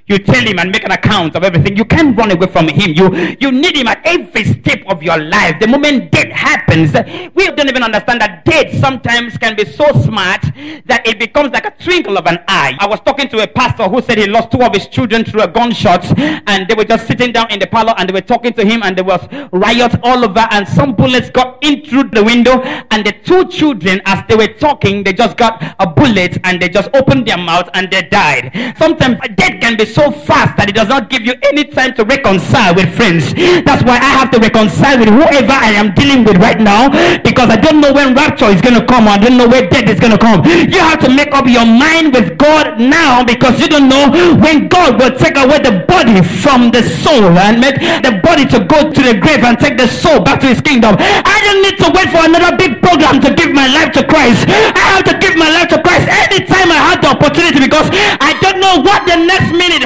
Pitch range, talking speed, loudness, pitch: 205-290 Hz, 250 wpm, -8 LUFS, 240 Hz